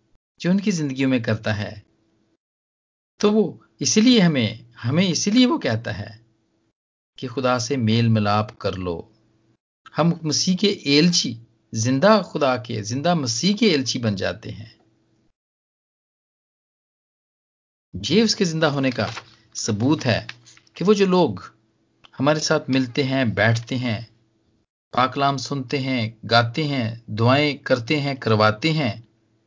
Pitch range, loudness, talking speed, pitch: 110-155 Hz, -21 LUFS, 130 wpm, 125 Hz